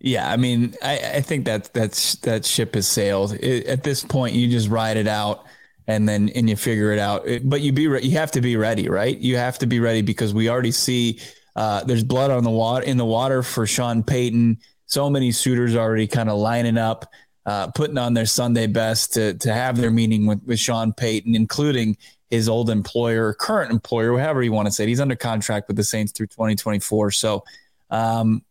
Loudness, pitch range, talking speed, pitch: -21 LUFS, 110-125 Hz, 220 wpm, 115 Hz